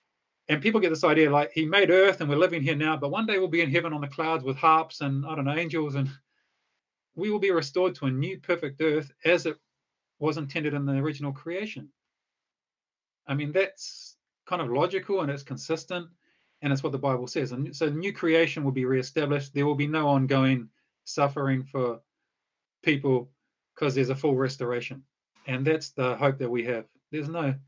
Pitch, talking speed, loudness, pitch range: 150 Hz, 205 wpm, -27 LUFS, 135-165 Hz